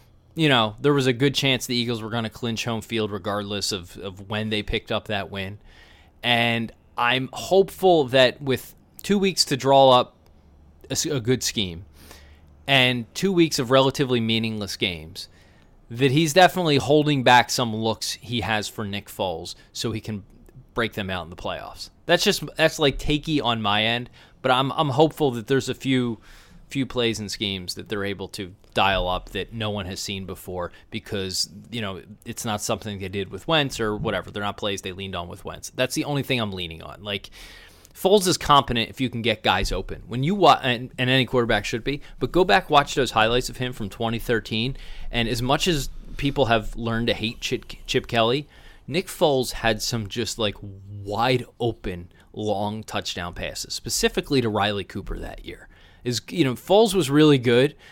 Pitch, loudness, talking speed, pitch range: 115 Hz, -23 LUFS, 195 wpm, 100-135 Hz